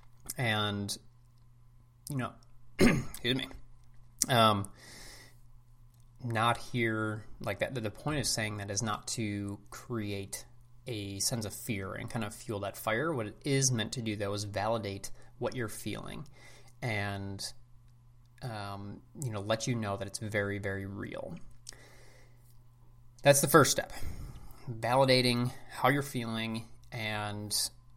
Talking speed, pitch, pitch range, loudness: 135 wpm, 120 Hz, 105-125 Hz, -32 LUFS